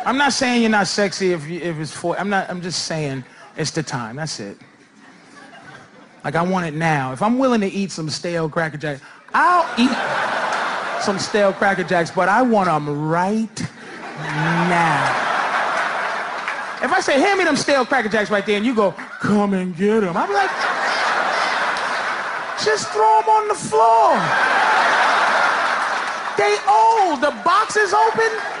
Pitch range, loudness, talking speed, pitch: 170-265 Hz, -18 LUFS, 165 wpm, 205 Hz